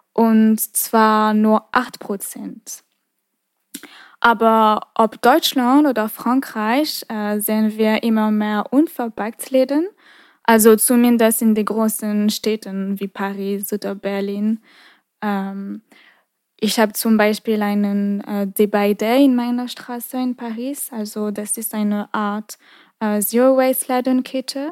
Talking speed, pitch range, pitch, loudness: 115 wpm, 210-245 Hz, 220 Hz, -18 LUFS